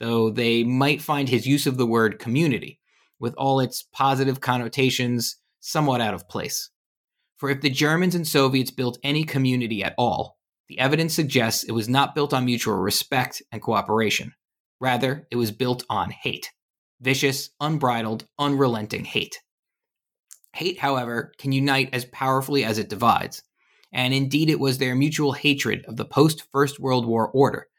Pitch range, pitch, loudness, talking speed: 120-140 Hz, 130 Hz, -23 LUFS, 160 wpm